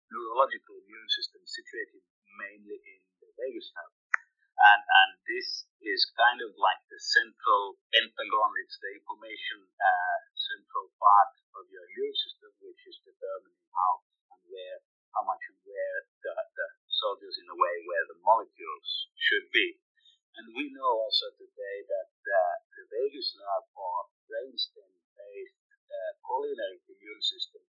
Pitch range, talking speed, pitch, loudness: 360-440 Hz, 145 wpm, 395 Hz, -29 LUFS